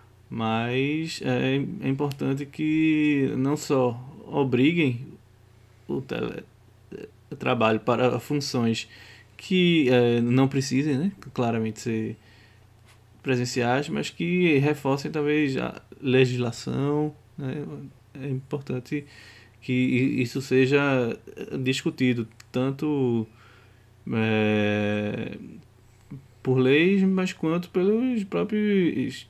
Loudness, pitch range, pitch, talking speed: -25 LUFS, 115-145 Hz, 130 Hz, 85 wpm